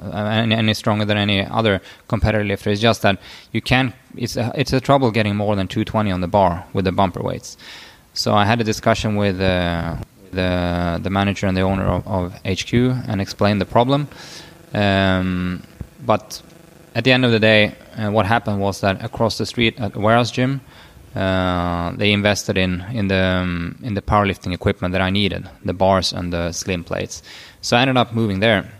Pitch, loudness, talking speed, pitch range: 105 Hz, -19 LUFS, 200 wpm, 95-115 Hz